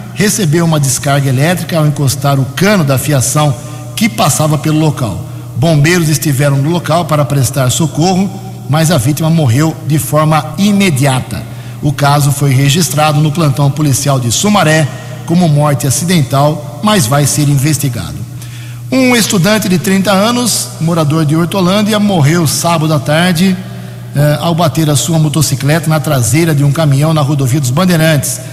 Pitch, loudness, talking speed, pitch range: 150 Hz, -10 LUFS, 150 wpm, 140-165 Hz